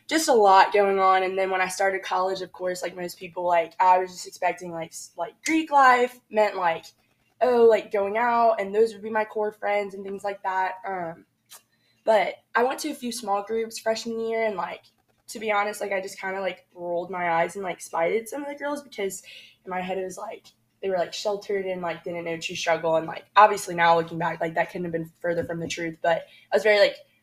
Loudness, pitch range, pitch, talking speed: -24 LUFS, 170-215 Hz, 190 Hz, 245 wpm